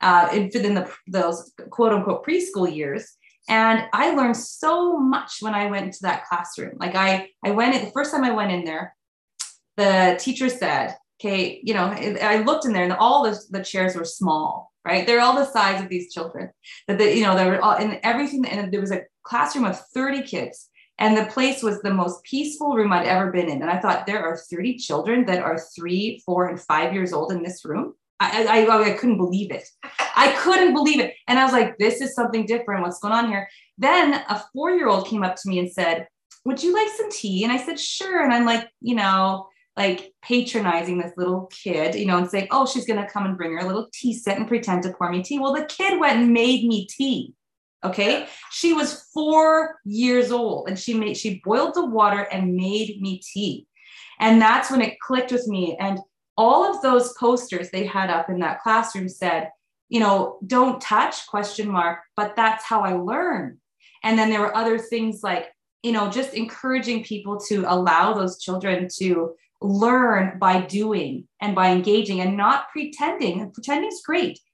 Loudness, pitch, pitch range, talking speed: -21 LUFS, 210 Hz, 185-245 Hz, 210 wpm